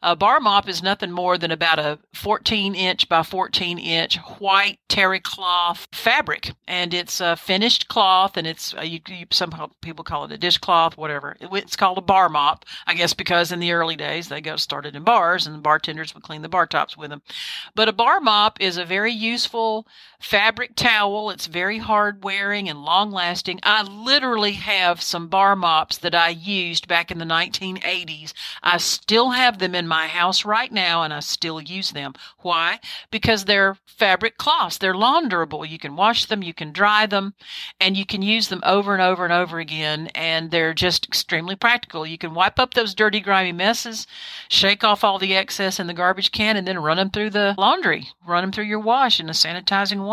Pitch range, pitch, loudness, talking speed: 170-205 Hz, 185 Hz, -19 LUFS, 200 wpm